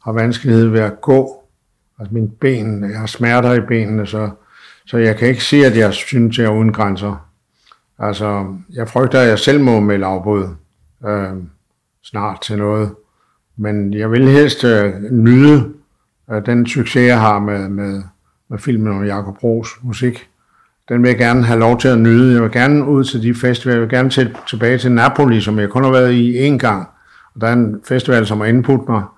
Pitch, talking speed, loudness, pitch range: 115 Hz, 205 wpm, -13 LUFS, 105-125 Hz